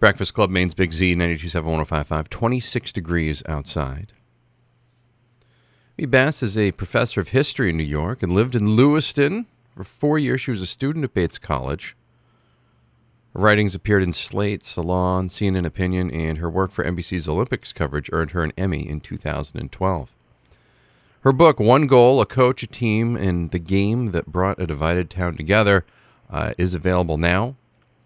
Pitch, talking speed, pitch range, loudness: 95 Hz, 160 wpm, 85-120 Hz, -21 LUFS